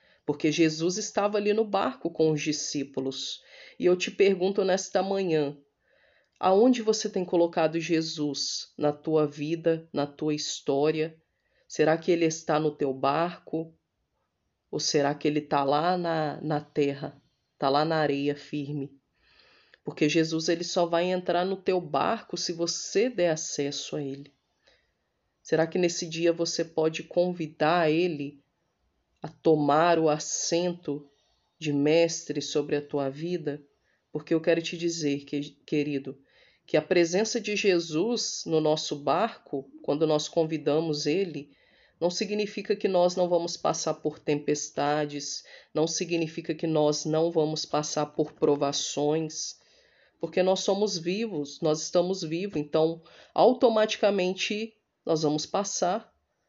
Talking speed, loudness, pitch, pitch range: 135 wpm, -27 LUFS, 160 Hz, 150-180 Hz